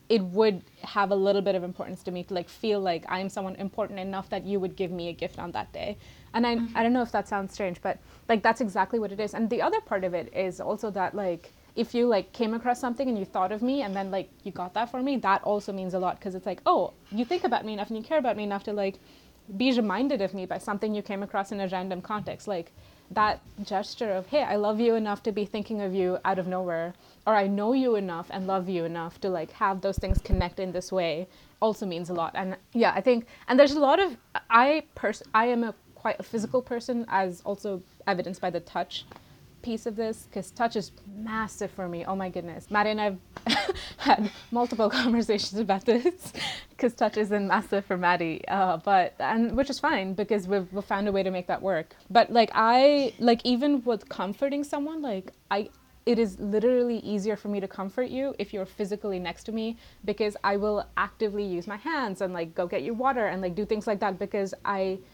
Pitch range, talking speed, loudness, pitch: 190-230 Hz, 240 wpm, -28 LUFS, 205 Hz